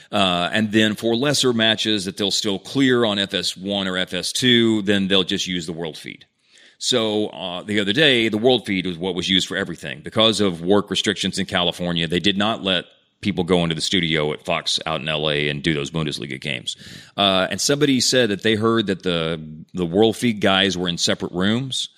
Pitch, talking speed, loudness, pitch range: 100 Hz, 210 wpm, -20 LUFS, 90-110 Hz